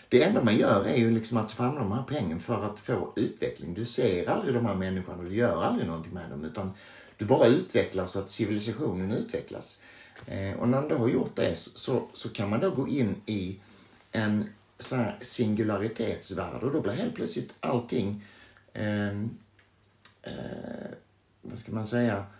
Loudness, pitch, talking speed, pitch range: -29 LUFS, 105 Hz, 175 wpm, 100-115 Hz